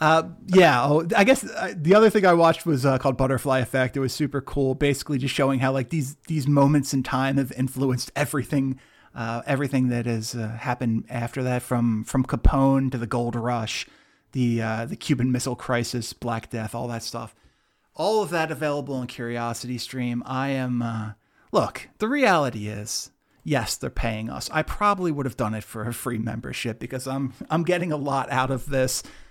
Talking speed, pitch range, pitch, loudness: 190 wpm, 120-145 Hz, 130 Hz, -24 LUFS